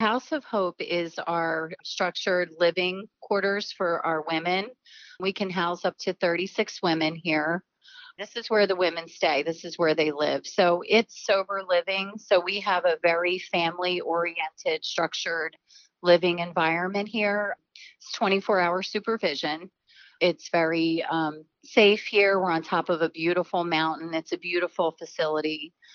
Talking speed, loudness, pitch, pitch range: 150 wpm, -26 LUFS, 180 Hz, 165-200 Hz